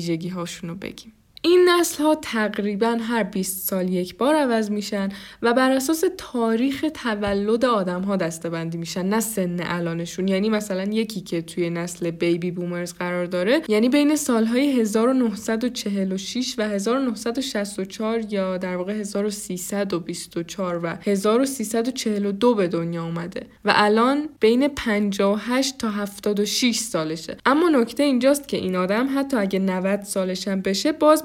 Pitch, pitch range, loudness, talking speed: 210 Hz, 185-240 Hz, -22 LUFS, 135 wpm